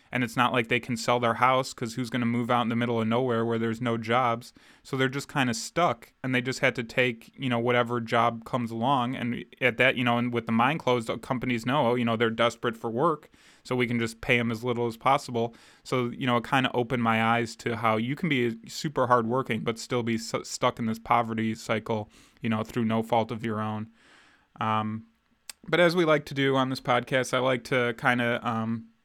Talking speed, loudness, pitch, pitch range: 245 wpm, -27 LUFS, 120 Hz, 115-130 Hz